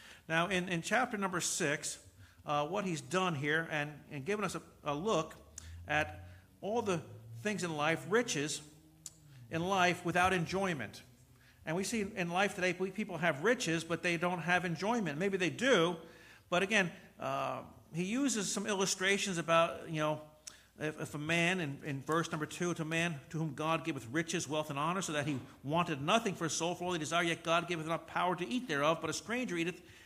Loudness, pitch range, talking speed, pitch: -34 LUFS, 150-180 Hz, 200 wpm, 165 Hz